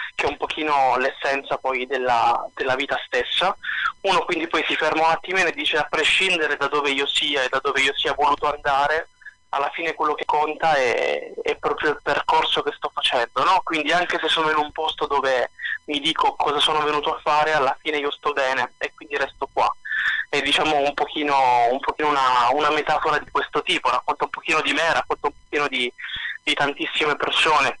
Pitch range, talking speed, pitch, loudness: 145-160 Hz, 200 wpm, 150 Hz, -21 LUFS